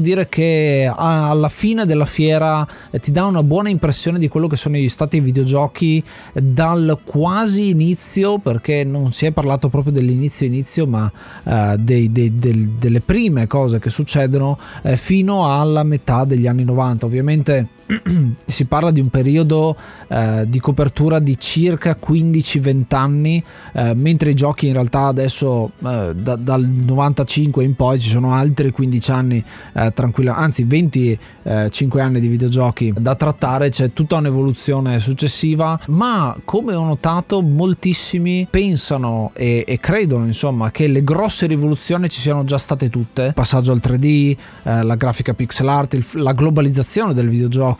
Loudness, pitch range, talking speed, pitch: -16 LUFS, 125-155 Hz, 155 wpm, 140 Hz